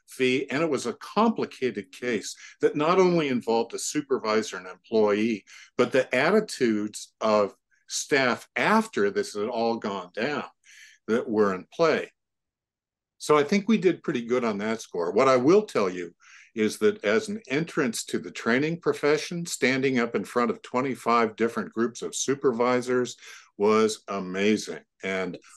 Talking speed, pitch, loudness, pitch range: 155 wpm, 125 Hz, -26 LUFS, 110-175 Hz